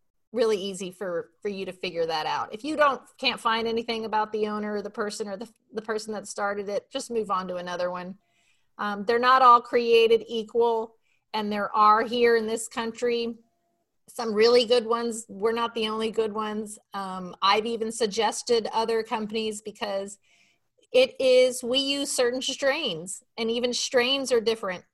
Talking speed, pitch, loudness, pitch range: 180 wpm, 225 Hz, -25 LUFS, 210-240 Hz